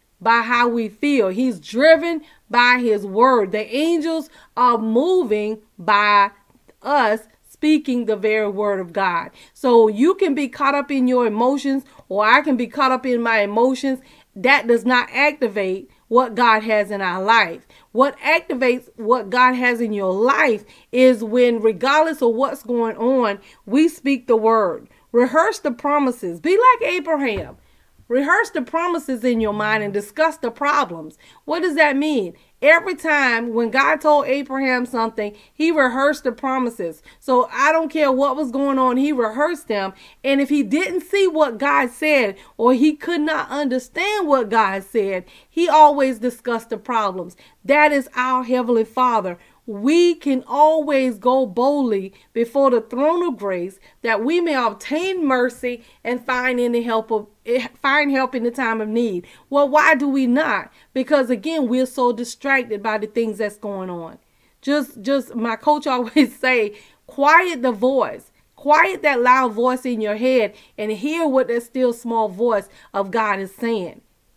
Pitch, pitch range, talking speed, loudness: 250 Hz, 225-290 Hz, 165 wpm, -18 LUFS